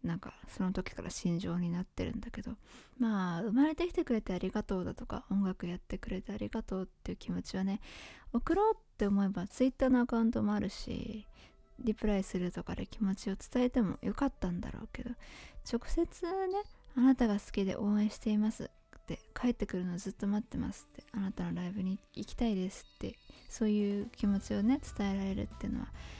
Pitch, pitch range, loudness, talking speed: 210 Hz, 195-240 Hz, -35 LUFS, 415 characters per minute